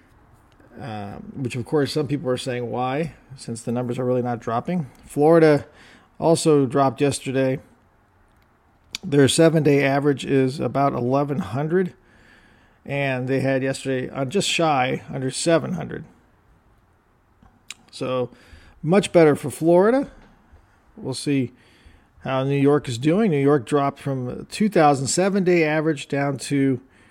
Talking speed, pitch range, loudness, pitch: 130 wpm, 120-150 Hz, -21 LUFS, 135 Hz